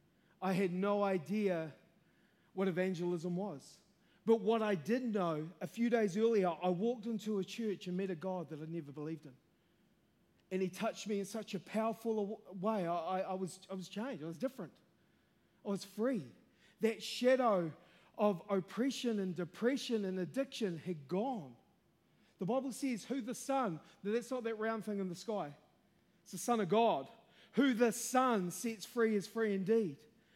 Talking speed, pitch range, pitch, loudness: 175 wpm, 180-225 Hz, 200 Hz, -37 LUFS